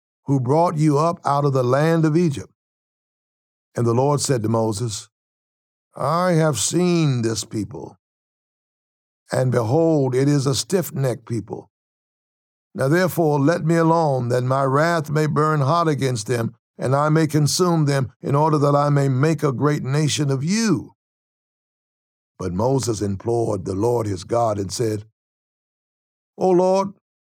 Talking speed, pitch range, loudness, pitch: 150 wpm, 120-160 Hz, -20 LUFS, 140 Hz